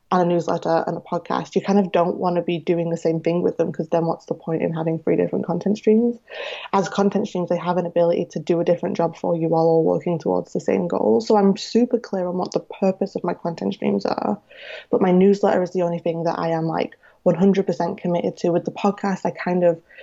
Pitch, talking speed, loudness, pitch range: 175 Hz, 250 wpm, -21 LUFS, 170-195 Hz